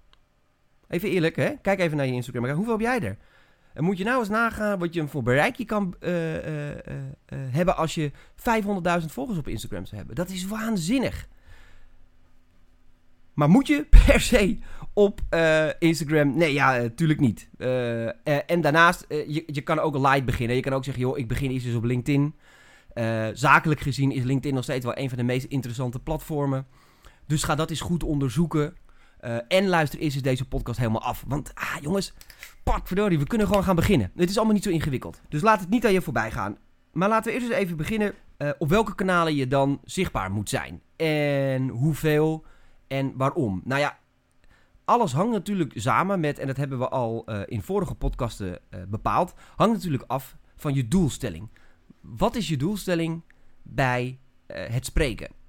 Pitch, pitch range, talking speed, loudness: 145 Hz, 125-175 Hz, 195 wpm, -25 LUFS